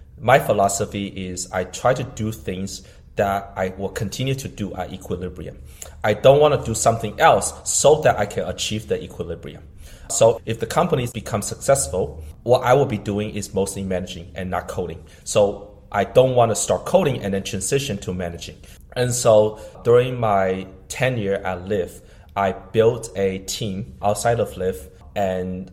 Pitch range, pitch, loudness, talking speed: 90-110 Hz, 100 Hz, -21 LUFS, 175 wpm